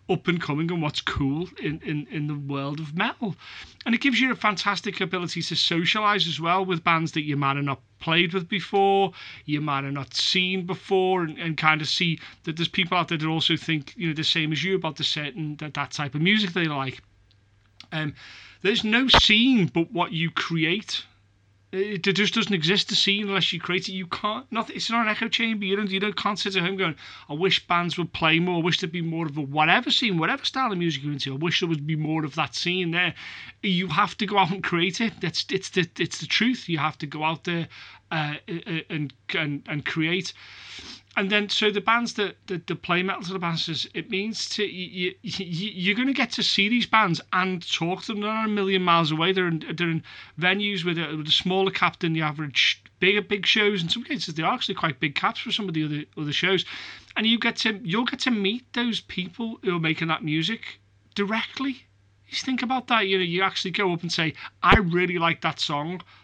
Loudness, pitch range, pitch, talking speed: -24 LUFS, 155-200 Hz, 180 Hz, 235 wpm